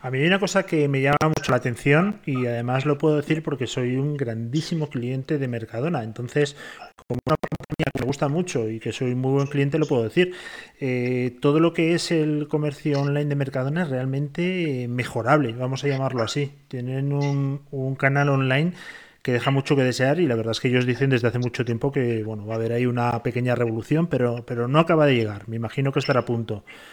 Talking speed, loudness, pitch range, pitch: 220 wpm, -23 LUFS, 125-150 Hz, 135 Hz